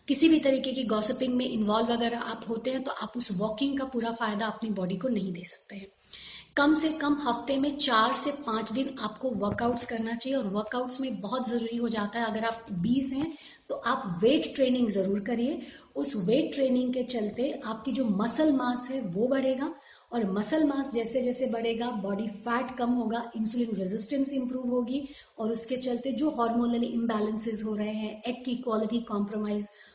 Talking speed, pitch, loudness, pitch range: 190 wpm, 240 Hz, -28 LUFS, 220-265 Hz